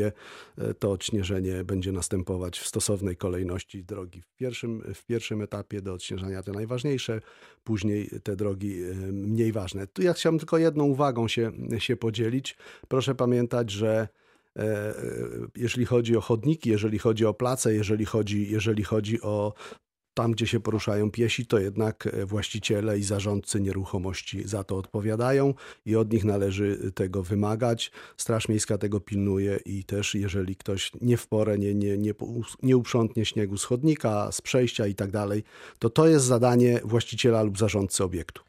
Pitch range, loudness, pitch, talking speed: 100-115 Hz, -27 LUFS, 110 Hz, 155 wpm